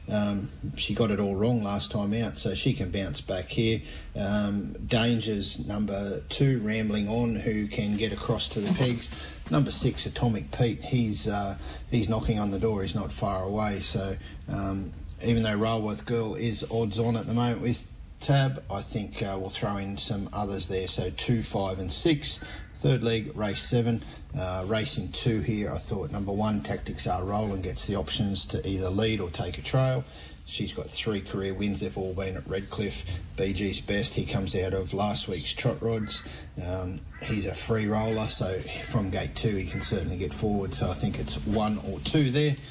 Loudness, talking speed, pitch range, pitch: -29 LUFS, 195 wpm, 95-115 Hz, 105 Hz